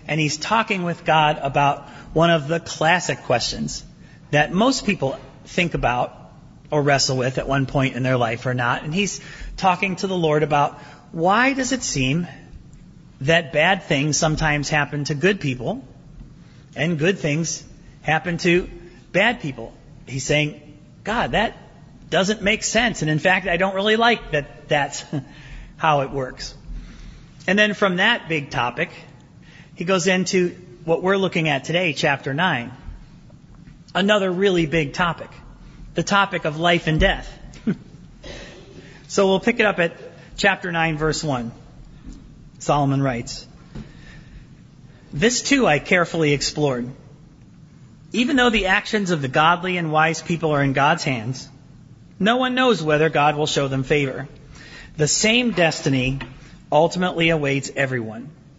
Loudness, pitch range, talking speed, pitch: -20 LUFS, 145-180 Hz, 145 wpm, 155 Hz